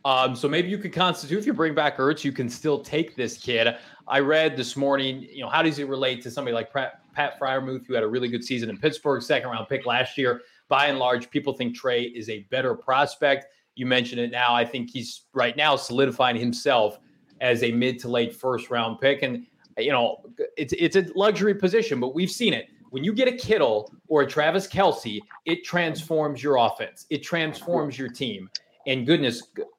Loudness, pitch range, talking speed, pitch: -24 LUFS, 125-165 Hz, 210 wpm, 135 Hz